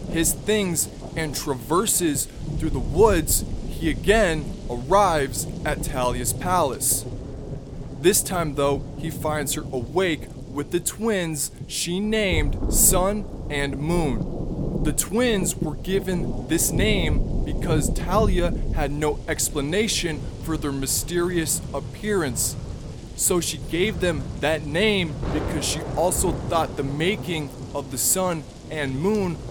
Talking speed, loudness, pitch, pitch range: 120 wpm, -23 LUFS, 150 Hz, 135-175 Hz